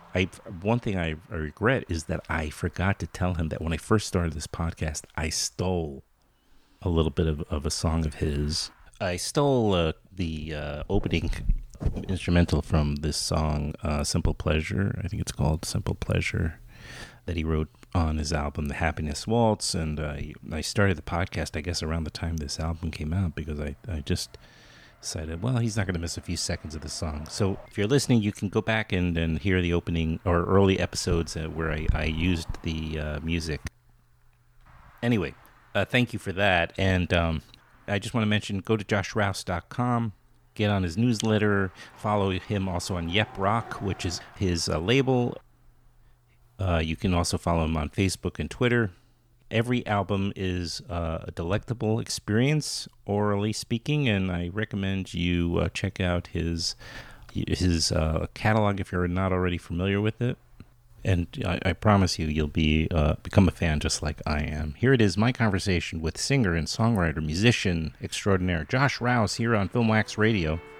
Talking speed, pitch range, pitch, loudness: 180 wpm, 80-110 Hz, 90 Hz, -27 LUFS